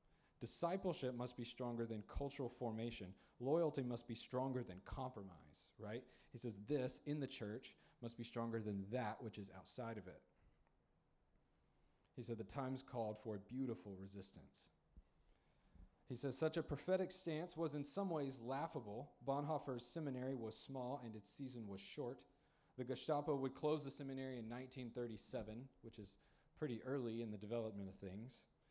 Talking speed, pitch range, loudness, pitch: 160 wpm, 110-140 Hz, -47 LUFS, 125 Hz